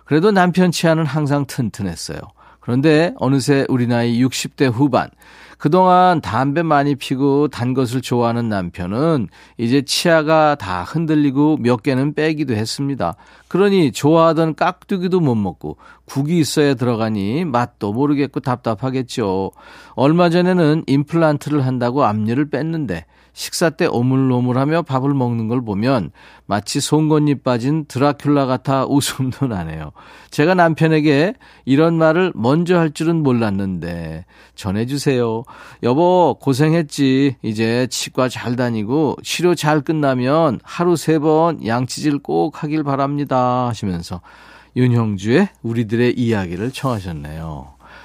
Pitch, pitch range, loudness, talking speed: 140 Hz, 120-155 Hz, -17 LUFS, 290 characters per minute